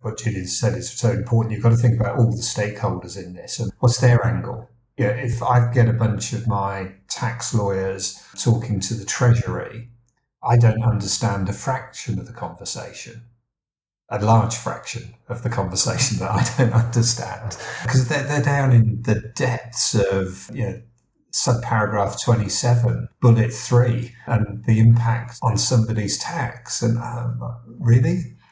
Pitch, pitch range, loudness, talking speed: 115 Hz, 110-120 Hz, -21 LUFS, 160 wpm